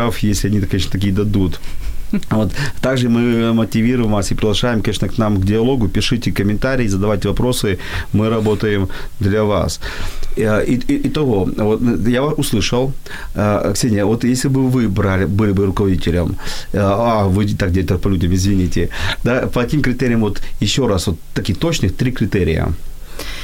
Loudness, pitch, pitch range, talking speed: -17 LUFS, 105 Hz, 95-120 Hz, 150 wpm